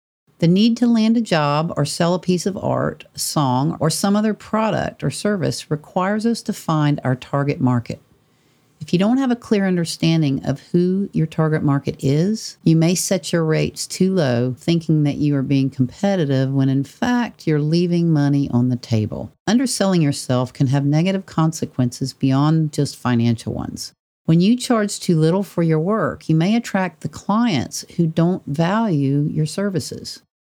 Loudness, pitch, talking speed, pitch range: -19 LUFS, 160 Hz, 175 wpm, 140-195 Hz